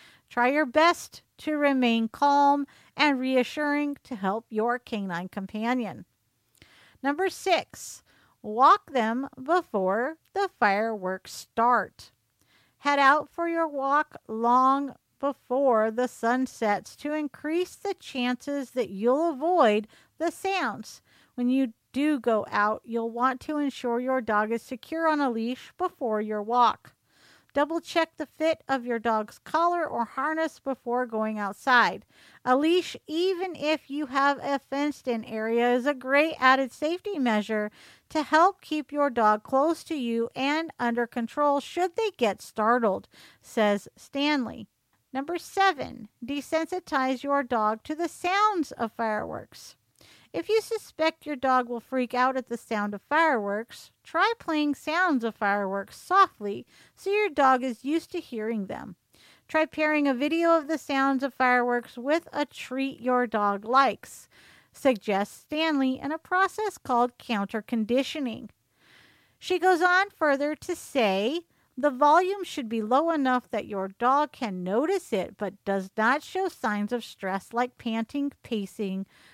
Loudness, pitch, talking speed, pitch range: -26 LUFS, 265 Hz, 145 wpm, 230-310 Hz